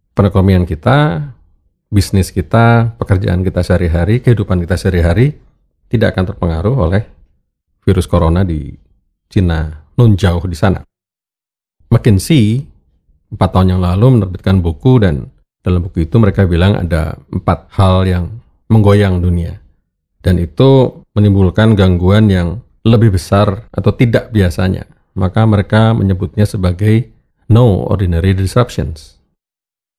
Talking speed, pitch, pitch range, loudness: 115 wpm, 95 Hz, 90-110 Hz, -12 LUFS